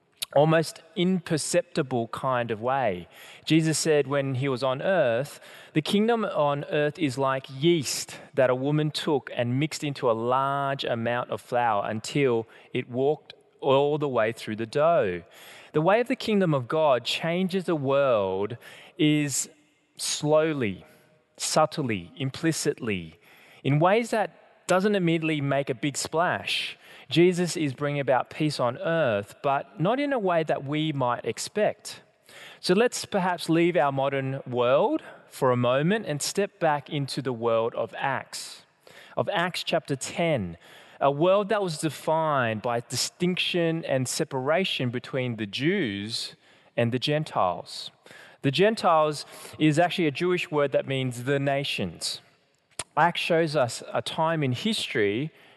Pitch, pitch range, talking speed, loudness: 145 Hz, 130-165 Hz, 145 wpm, -26 LUFS